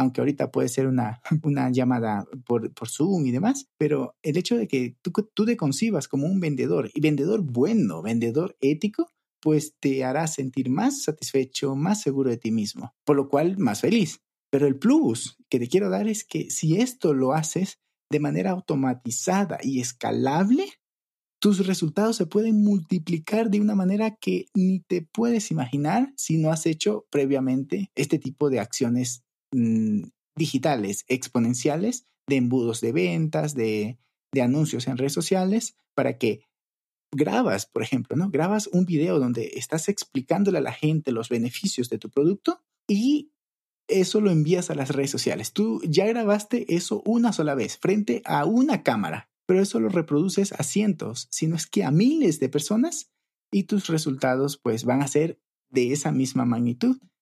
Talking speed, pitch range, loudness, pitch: 170 wpm, 130-205 Hz, -24 LUFS, 160 Hz